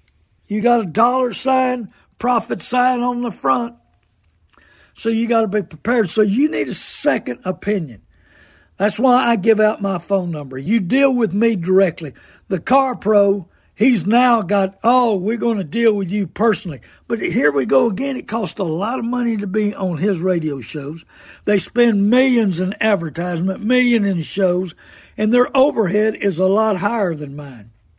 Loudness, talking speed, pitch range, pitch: -18 LUFS, 180 wpm, 180-235 Hz, 205 Hz